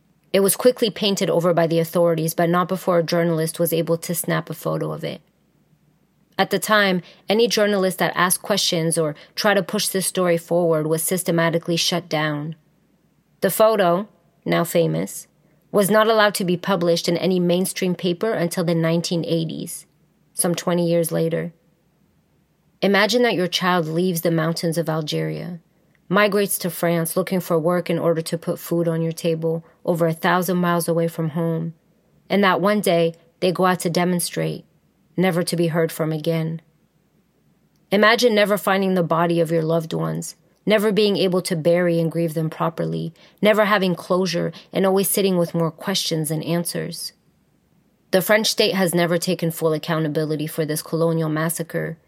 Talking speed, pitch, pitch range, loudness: 170 wpm, 170 Hz, 165-185 Hz, -20 LUFS